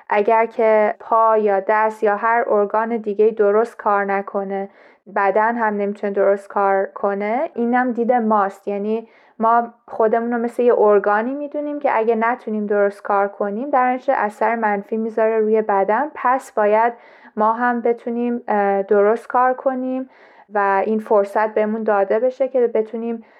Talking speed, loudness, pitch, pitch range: 150 wpm, -18 LUFS, 220 Hz, 205-235 Hz